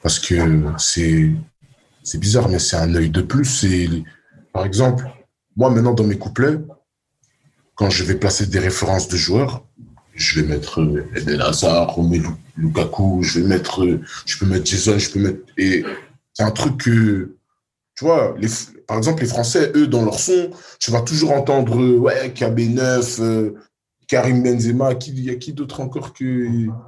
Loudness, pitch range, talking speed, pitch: -18 LUFS, 95-130 Hz, 165 wpm, 115 Hz